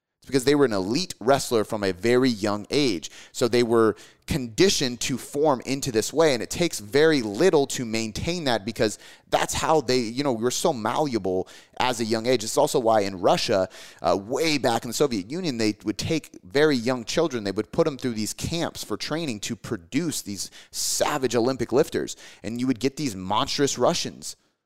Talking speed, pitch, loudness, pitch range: 195 wpm, 125 Hz, -24 LUFS, 110-145 Hz